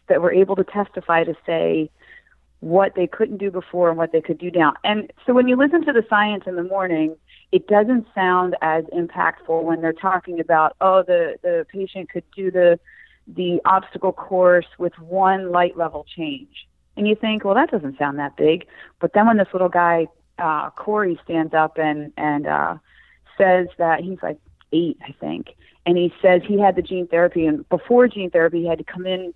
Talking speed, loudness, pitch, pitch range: 200 wpm, -19 LUFS, 180 Hz, 165-200 Hz